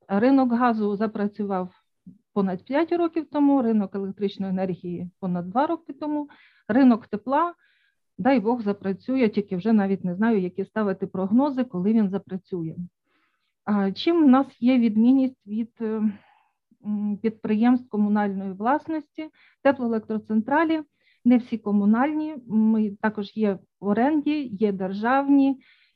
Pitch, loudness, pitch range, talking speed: 220 Hz, -24 LUFS, 200-270 Hz, 115 wpm